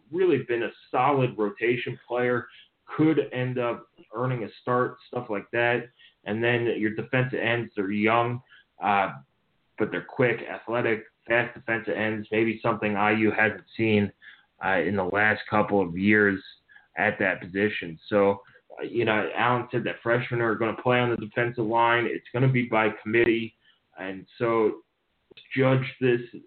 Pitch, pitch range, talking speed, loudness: 115 Hz, 105-120 Hz, 160 wpm, -25 LUFS